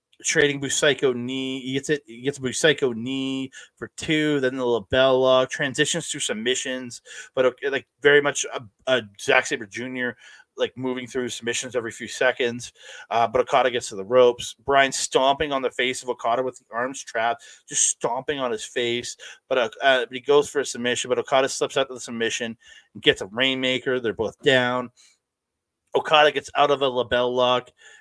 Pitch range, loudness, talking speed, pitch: 120-135 Hz, -23 LUFS, 190 wpm, 130 Hz